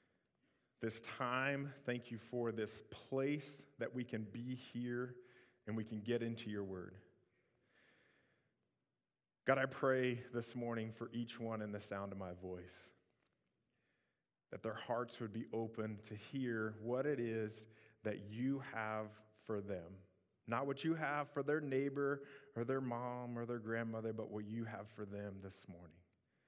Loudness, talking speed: -43 LUFS, 160 wpm